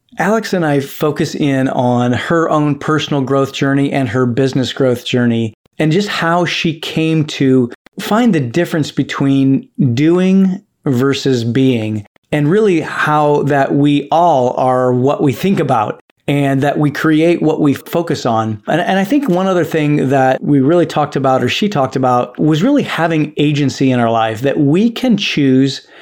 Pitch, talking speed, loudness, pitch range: 145 Hz, 175 wpm, -14 LUFS, 135-165 Hz